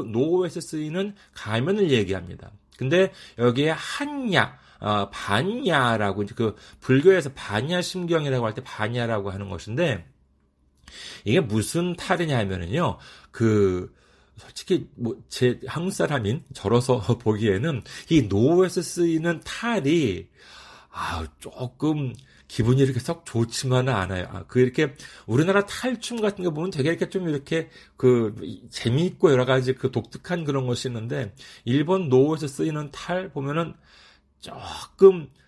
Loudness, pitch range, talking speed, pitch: -24 LUFS, 115-170 Hz, 285 characters per minute, 135 Hz